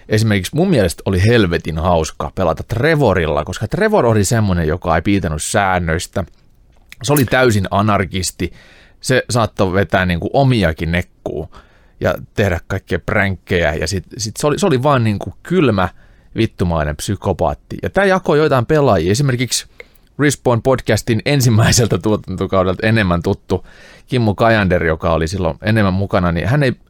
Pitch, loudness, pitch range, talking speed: 100 Hz, -16 LUFS, 90-120 Hz, 145 wpm